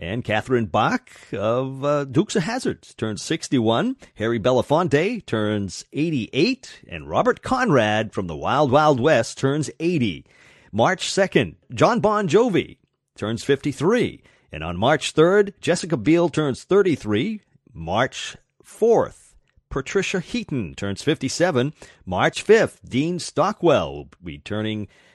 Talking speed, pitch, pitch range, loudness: 120 wpm, 145 Hz, 110-175 Hz, -21 LUFS